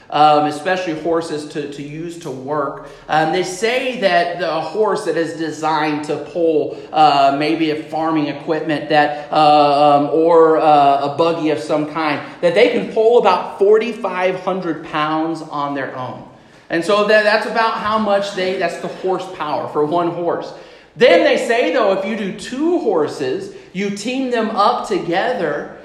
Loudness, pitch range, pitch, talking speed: -16 LUFS, 150-200 Hz, 165 Hz, 165 wpm